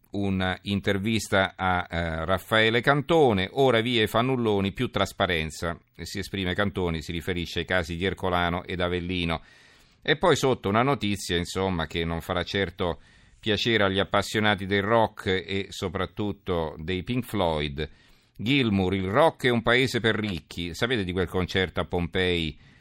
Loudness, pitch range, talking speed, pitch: -26 LUFS, 90-105 Hz, 145 wpm, 95 Hz